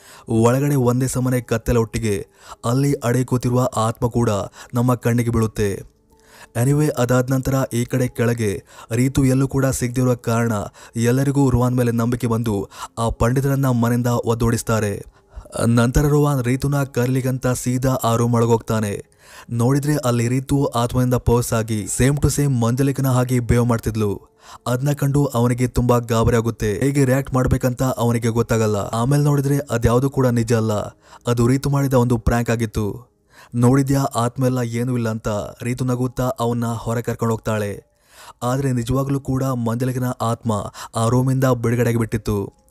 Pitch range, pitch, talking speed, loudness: 115-130 Hz, 120 Hz, 135 wpm, -20 LUFS